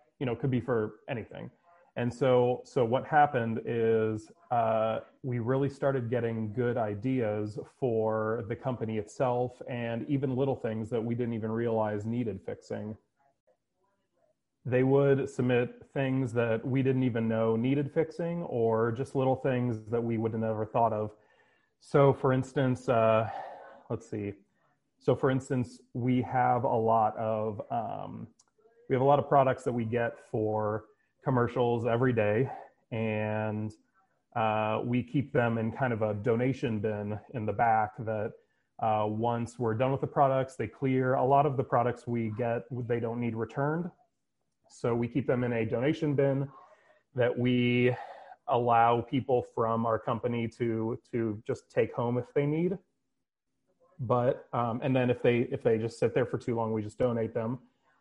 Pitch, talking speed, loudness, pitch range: 120 Hz, 165 wpm, -30 LUFS, 115-130 Hz